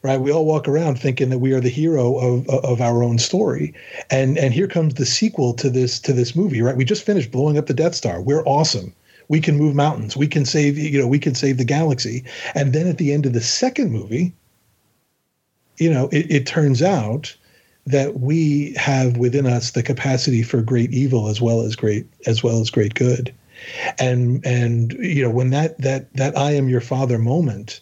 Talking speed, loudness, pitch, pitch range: 215 wpm, -19 LUFS, 135 Hz, 120-150 Hz